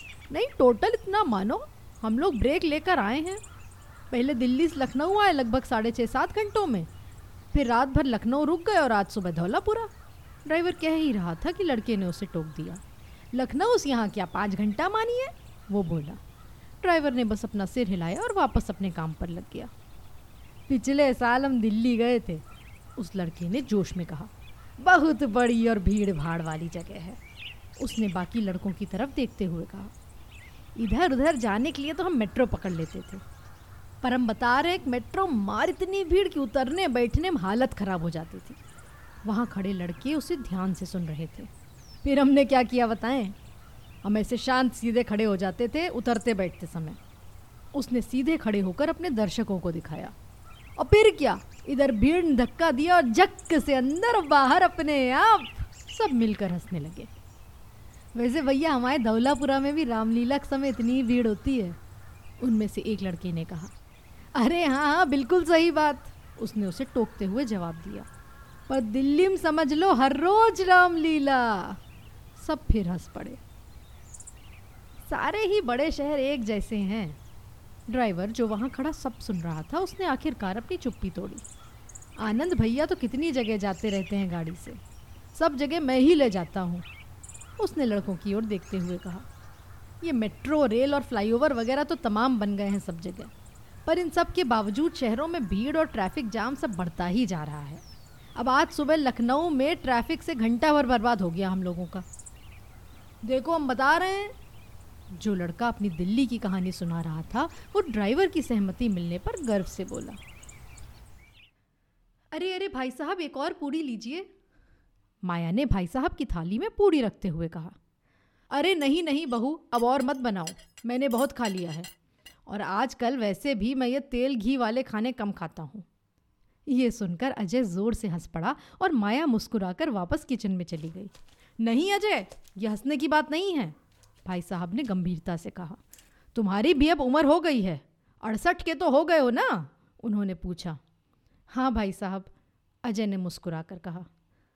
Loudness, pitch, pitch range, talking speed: -27 LUFS, 235 Hz, 190-290 Hz, 175 wpm